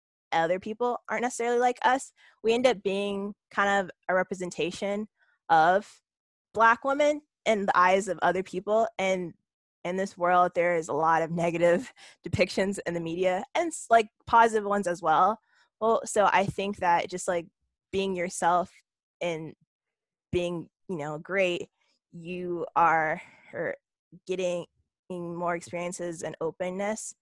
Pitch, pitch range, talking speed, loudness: 185 Hz, 175-215 Hz, 140 wpm, -27 LUFS